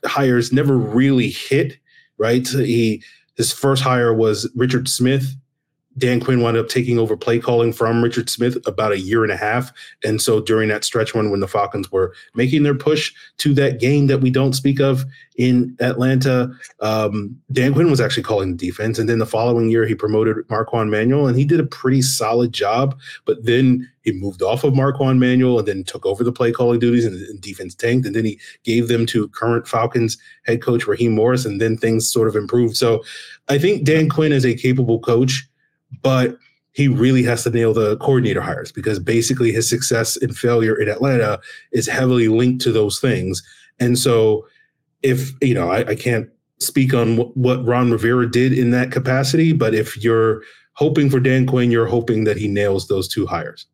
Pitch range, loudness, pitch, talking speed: 115-130 Hz, -17 LUFS, 120 Hz, 200 wpm